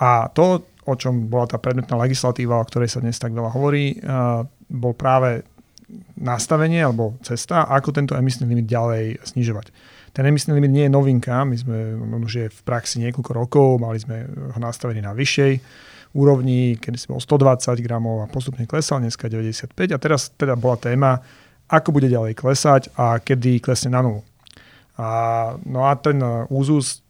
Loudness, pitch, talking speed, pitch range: -20 LUFS, 125 Hz, 170 wpm, 120-140 Hz